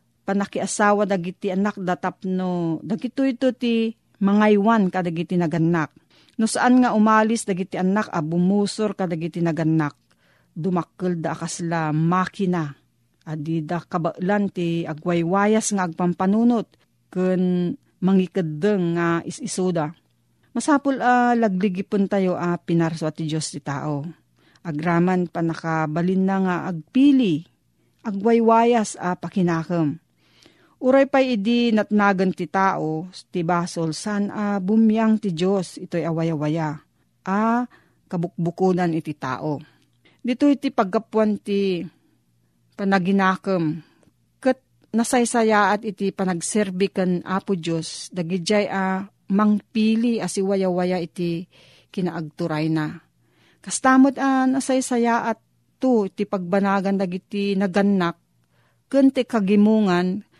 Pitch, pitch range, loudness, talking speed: 185 Hz, 170-210 Hz, -22 LUFS, 110 wpm